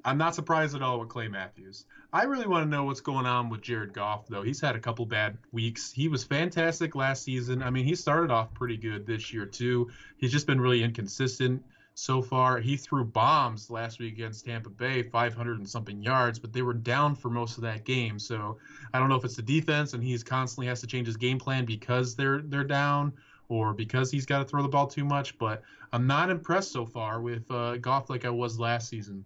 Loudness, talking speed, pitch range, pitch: -29 LUFS, 235 wpm, 115-135 Hz, 125 Hz